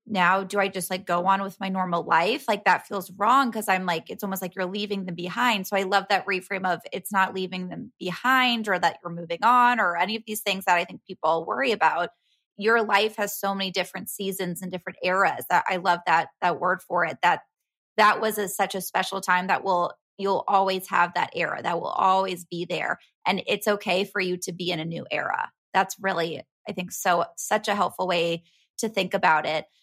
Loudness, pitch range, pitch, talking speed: -25 LUFS, 180-200 Hz, 190 Hz, 230 wpm